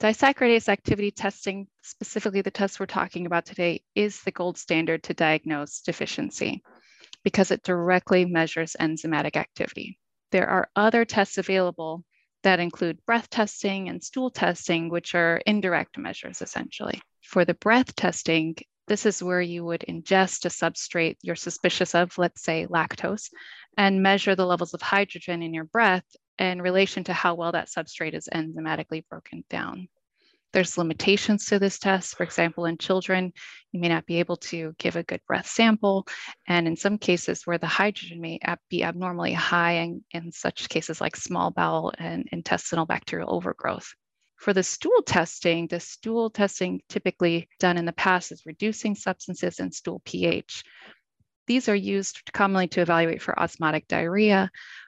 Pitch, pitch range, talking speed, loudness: 180 Hz, 170-200 Hz, 160 wpm, -25 LUFS